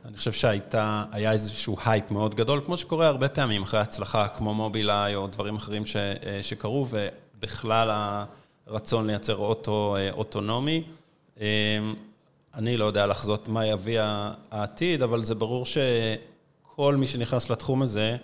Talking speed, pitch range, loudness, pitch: 135 wpm, 105-125 Hz, -27 LUFS, 110 Hz